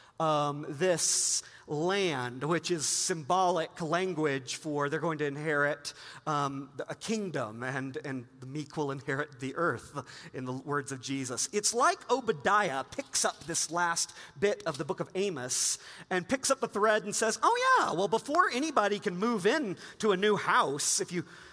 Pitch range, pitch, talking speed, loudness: 145-205 Hz, 170 Hz, 175 wpm, -30 LUFS